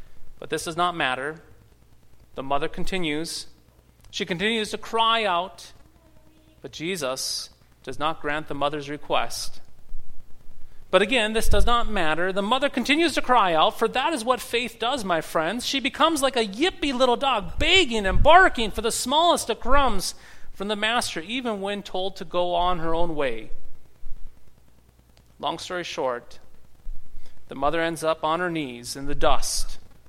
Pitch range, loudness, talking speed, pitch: 145-240 Hz, -24 LUFS, 160 wpm, 185 Hz